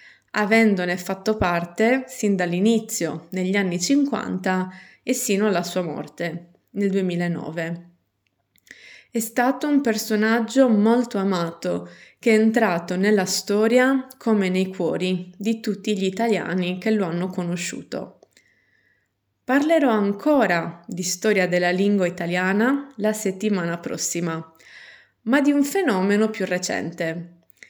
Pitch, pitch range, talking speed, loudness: 195 Hz, 175-225 Hz, 115 wpm, -22 LUFS